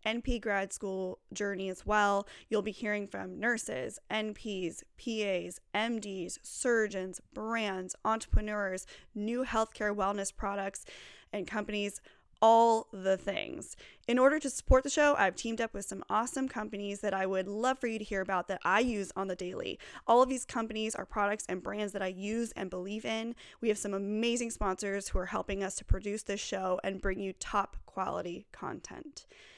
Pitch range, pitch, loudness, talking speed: 195-225 Hz, 210 Hz, -33 LUFS, 175 wpm